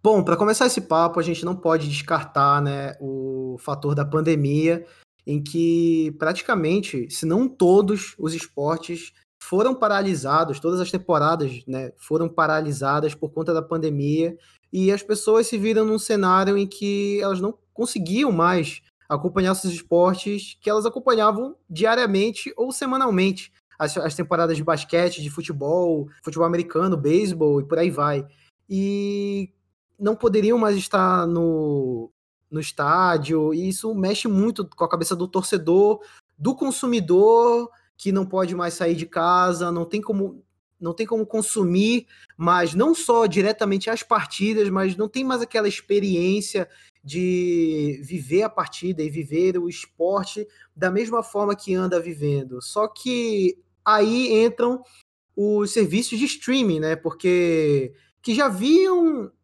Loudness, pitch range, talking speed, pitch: -22 LUFS, 160-215 Hz, 145 wpm, 185 Hz